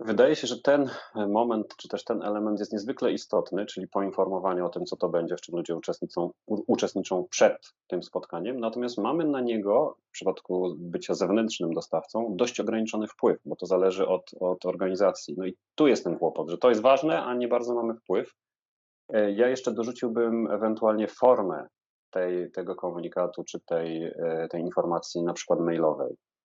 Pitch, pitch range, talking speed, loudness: 105 Hz, 90-120 Hz, 170 wpm, -28 LUFS